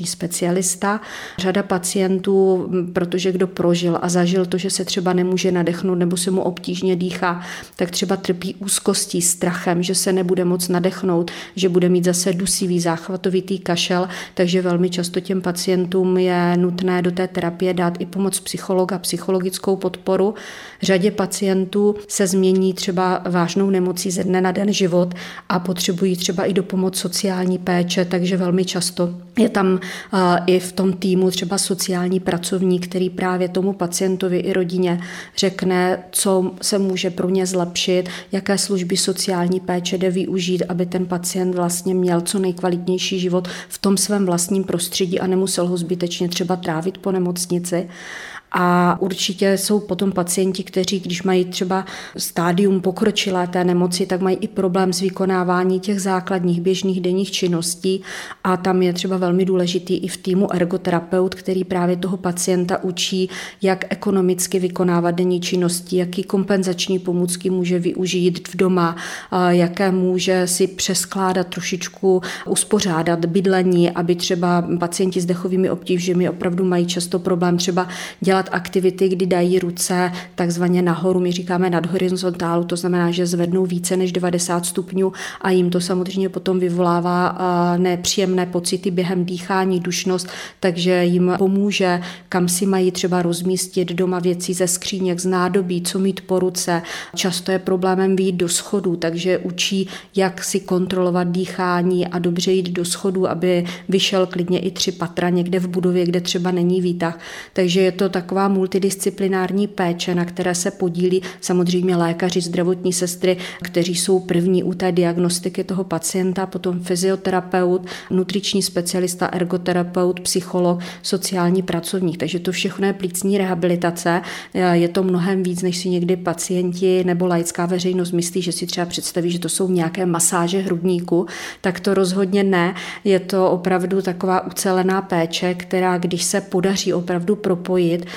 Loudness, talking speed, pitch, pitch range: -19 LUFS, 150 wpm, 185 Hz, 180-190 Hz